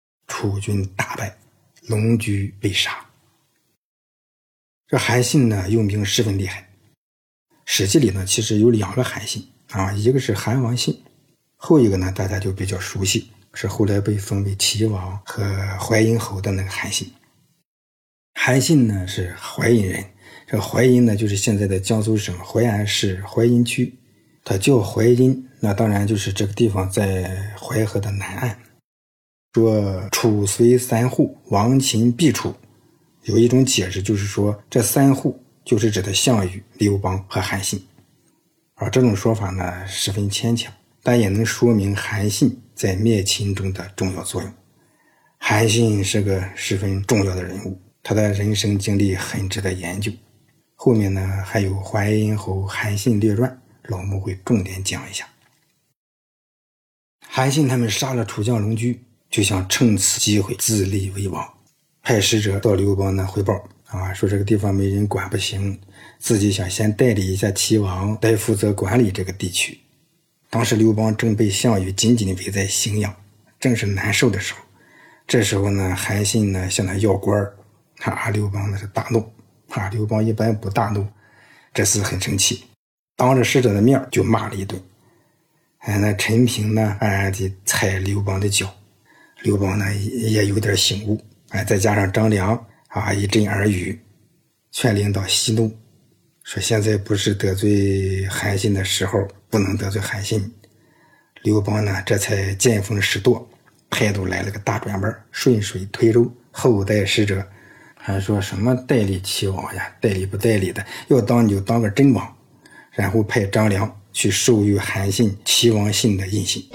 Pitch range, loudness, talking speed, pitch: 100-115 Hz, -20 LUFS, 230 characters per minute, 105 Hz